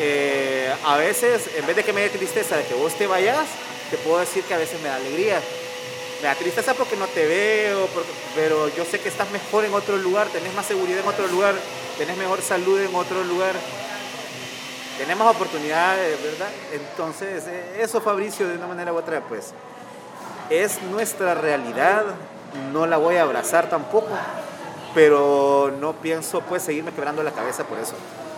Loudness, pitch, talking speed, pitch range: -22 LUFS, 185 Hz, 180 wpm, 160-220 Hz